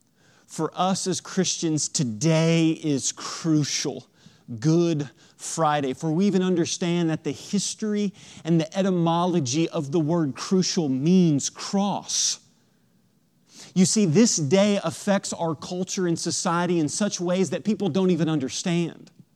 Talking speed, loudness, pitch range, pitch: 130 wpm, -24 LUFS, 160-185 Hz, 170 Hz